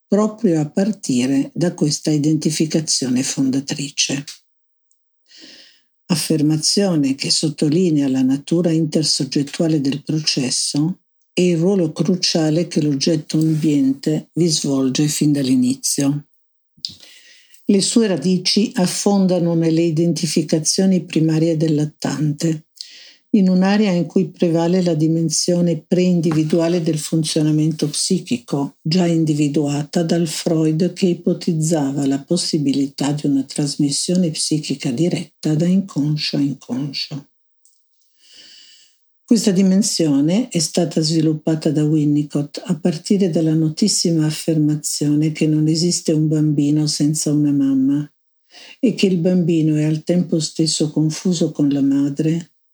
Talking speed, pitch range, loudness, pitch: 105 wpm, 150-175 Hz, -18 LUFS, 160 Hz